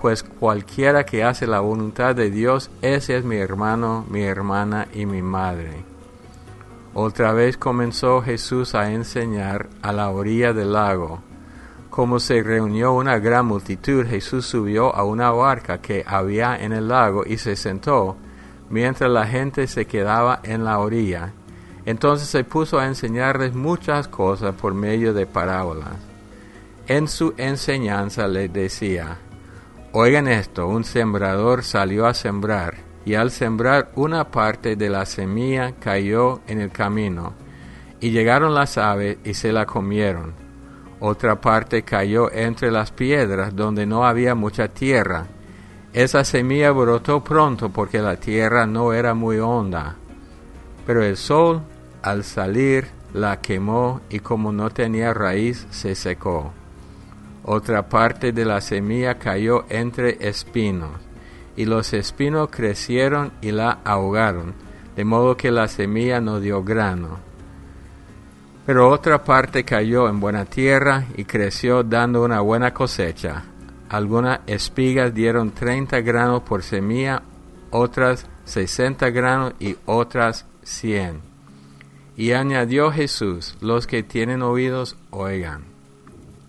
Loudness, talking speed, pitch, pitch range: -20 LUFS, 135 wpm, 110 Hz, 100-125 Hz